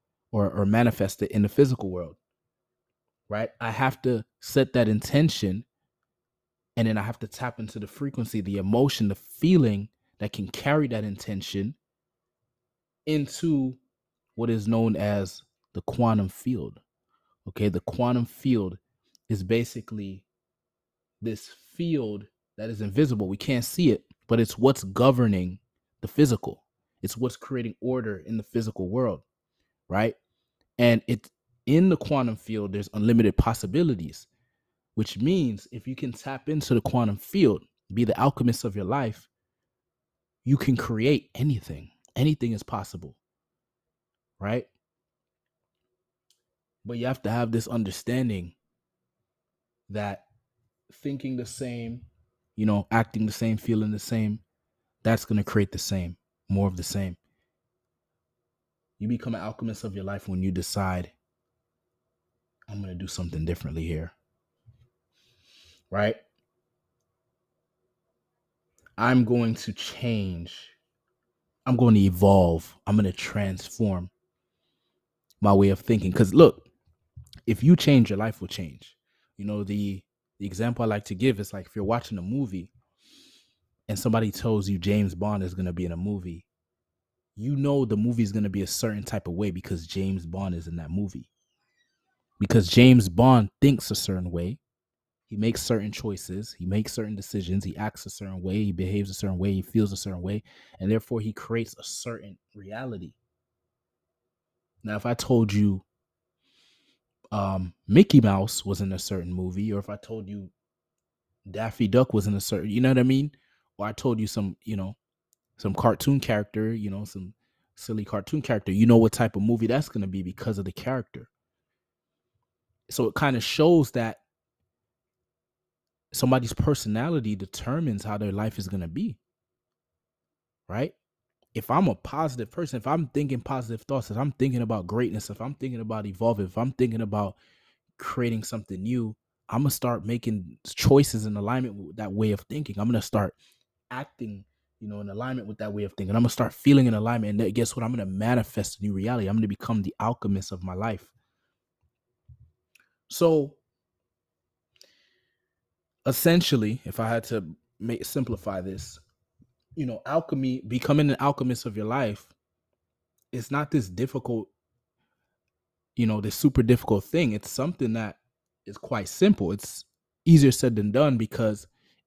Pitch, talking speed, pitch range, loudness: 110 Hz, 160 wpm, 100-125 Hz, -26 LUFS